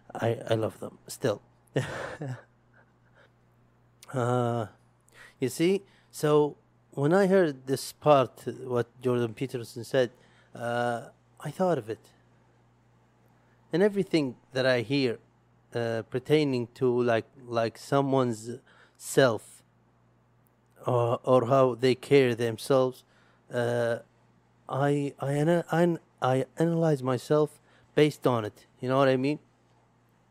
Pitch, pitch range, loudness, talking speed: 130 Hz, 115-140 Hz, -28 LUFS, 110 wpm